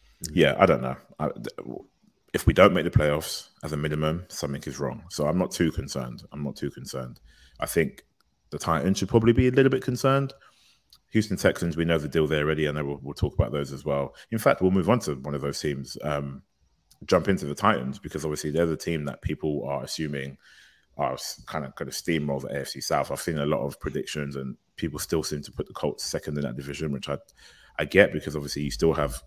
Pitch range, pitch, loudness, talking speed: 70-85 Hz, 75 Hz, -26 LUFS, 230 wpm